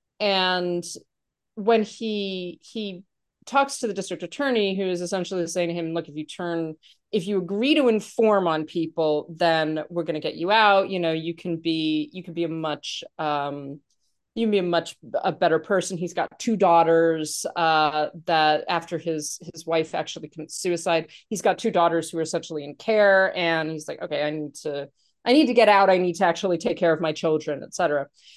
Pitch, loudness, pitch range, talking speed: 170 Hz, -23 LUFS, 160-195 Hz, 205 wpm